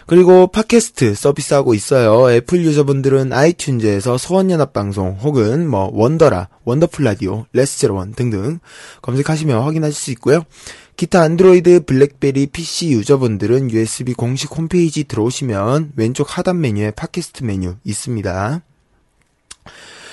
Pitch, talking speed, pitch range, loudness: 140 Hz, 340 characters per minute, 115-160 Hz, -15 LUFS